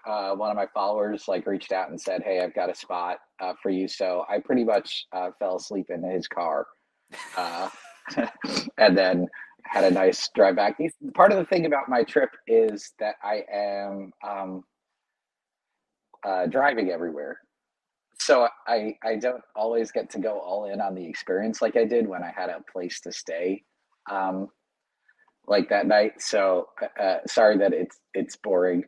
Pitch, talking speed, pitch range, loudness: 100 Hz, 175 wpm, 95-120 Hz, -25 LUFS